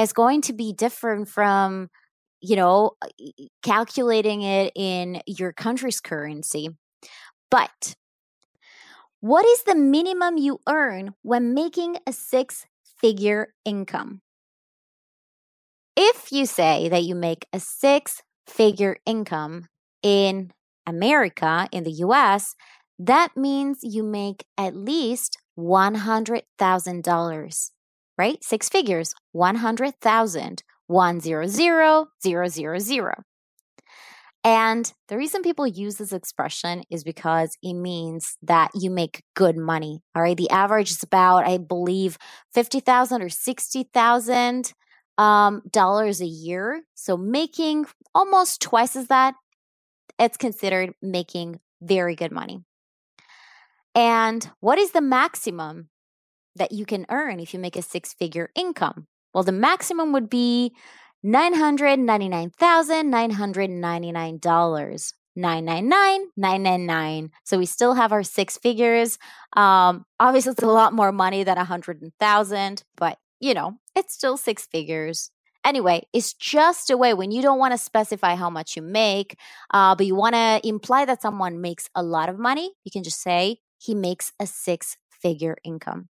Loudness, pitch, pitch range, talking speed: -22 LUFS, 205 Hz, 175-245 Hz, 140 wpm